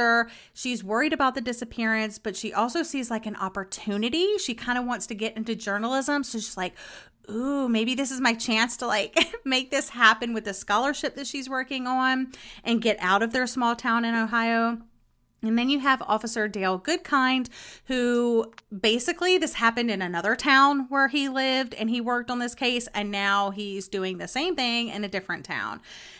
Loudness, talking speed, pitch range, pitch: -25 LUFS, 190 wpm, 220-260 Hz, 235 Hz